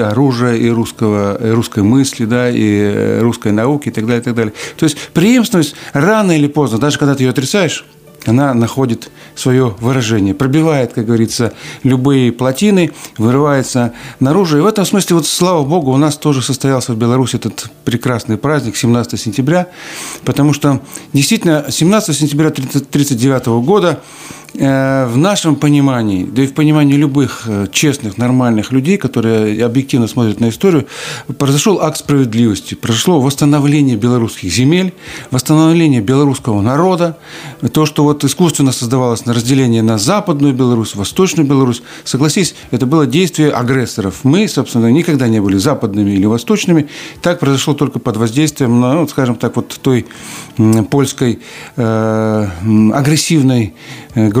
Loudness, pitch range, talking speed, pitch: -12 LUFS, 115-150 Hz, 140 wpm, 135 Hz